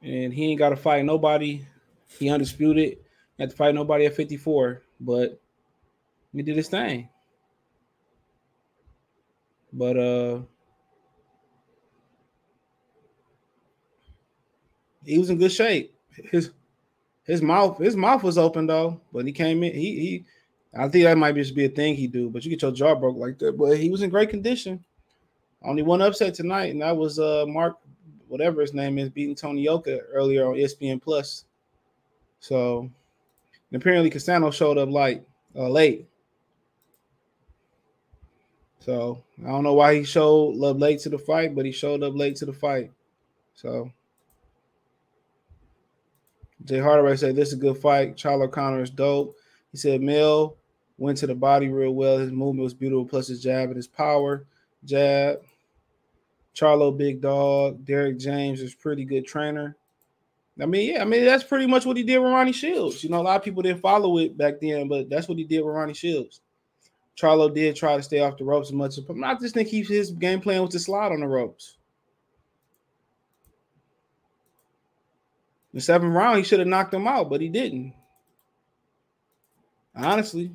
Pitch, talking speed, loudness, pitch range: 145 Hz, 170 wpm, -23 LUFS, 135-170 Hz